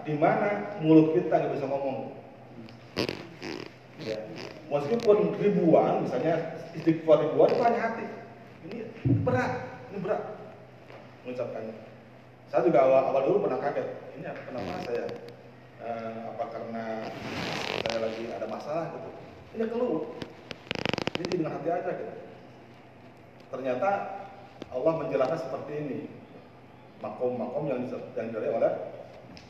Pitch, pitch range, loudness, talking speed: 150 Hz, 115-175 Hz, -28 LUFS, 110 wpm